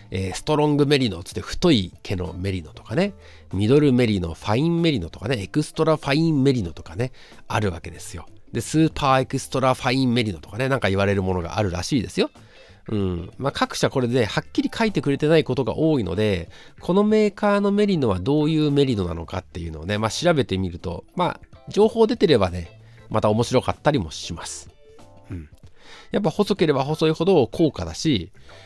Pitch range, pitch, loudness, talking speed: 95-150 Hz, 120 Hz, -22 LUFS, 425 characters per minute